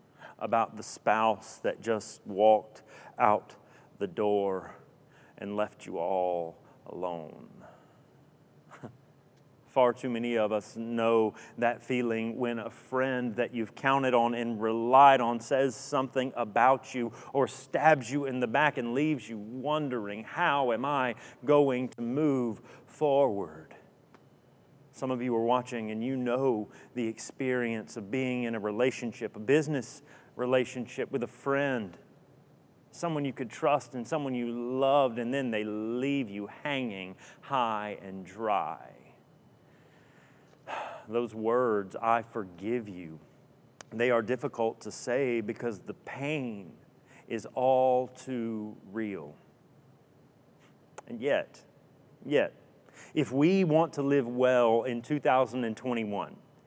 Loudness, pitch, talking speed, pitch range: -30 LUFS, 120 Hz, 125 wpm, 110-130 Hz